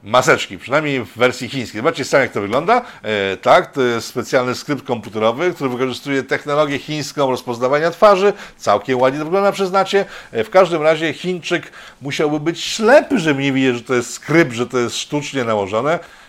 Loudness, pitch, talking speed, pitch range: -17 LUFS, 140 Hz, 175 wpm, 125-170 Hz